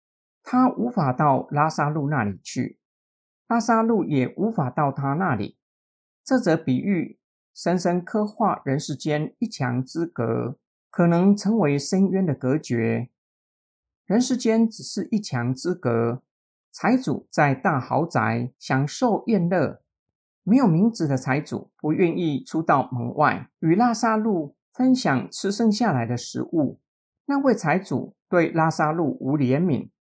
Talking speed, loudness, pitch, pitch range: 200 characters per minute, -23 LUFS, 160 Hz, 130-210 Hz